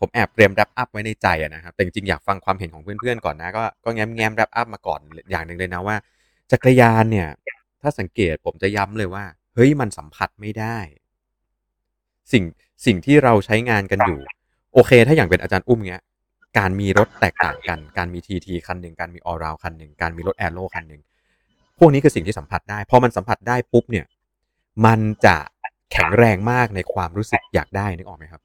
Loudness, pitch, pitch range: -19 LUFS, 100 Hz, 90-115 Hz